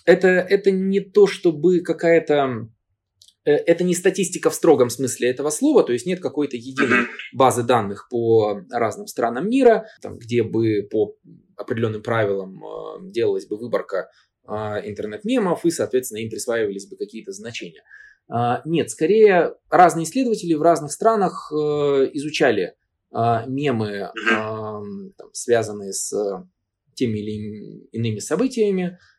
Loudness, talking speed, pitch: -20 LUFS, 115 wpm, 145 Hz